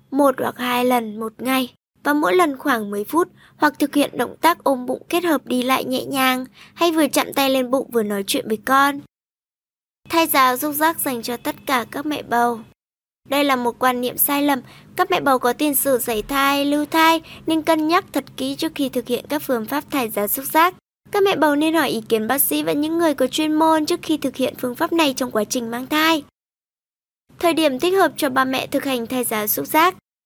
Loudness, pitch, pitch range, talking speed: -19 LUFS, 275 Hz, 255-315 Hz, 240 wpm